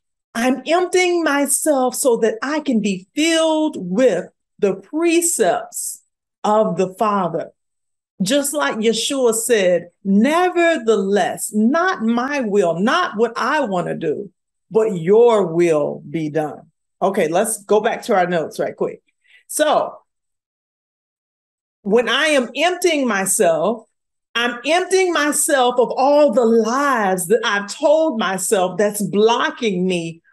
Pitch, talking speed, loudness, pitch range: 235 Hz, 125 wpm, -17 LUFS, 205-300 Hz